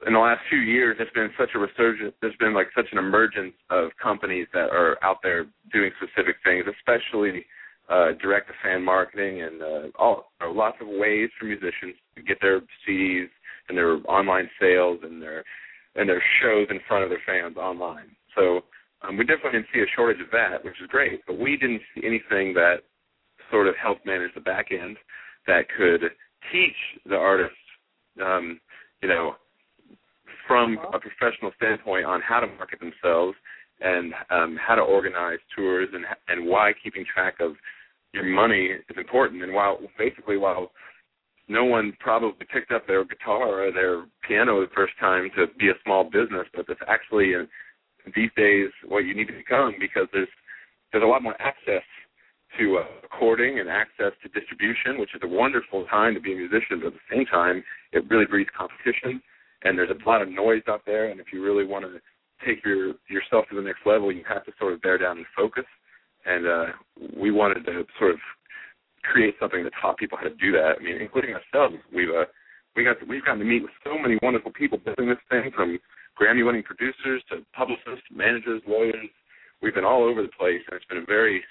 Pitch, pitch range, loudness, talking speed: 100 Hz, 90-115 Hz, -24 LUFS, 195 wpm